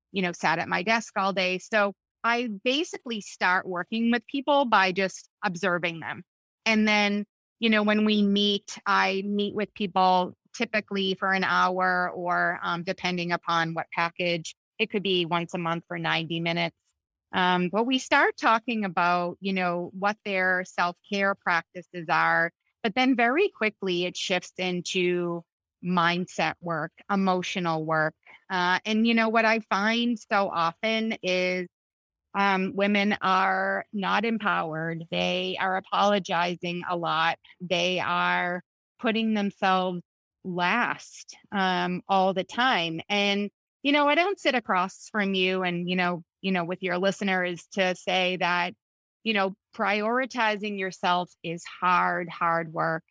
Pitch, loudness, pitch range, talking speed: 185 Hz, -26 LUFS, 175-210 Hz, 150 wpm